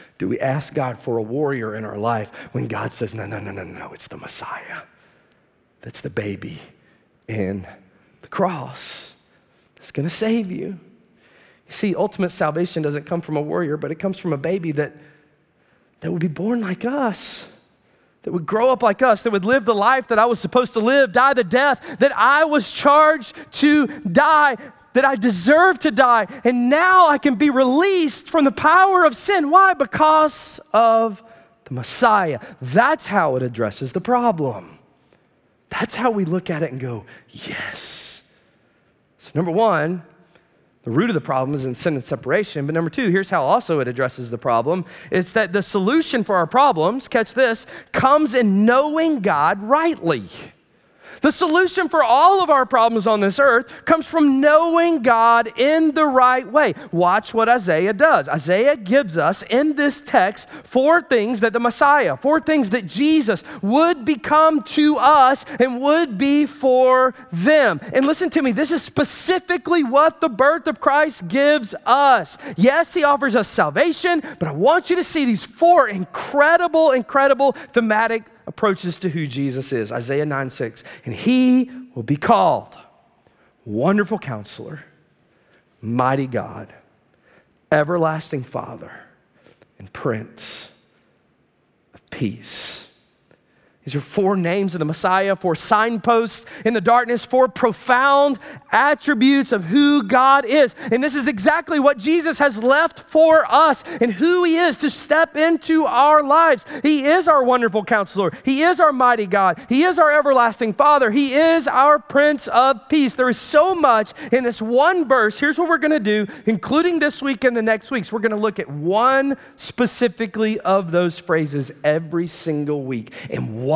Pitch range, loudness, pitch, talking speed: 185-295 Hz, -17 LUFS, 245 Hz, 170 wpm